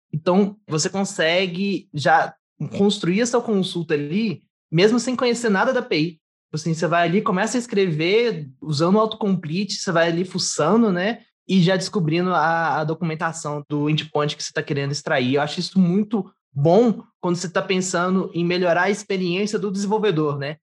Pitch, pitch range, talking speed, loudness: 180 Hz, 160-205 Hz, 170 wpm, -21 LUFS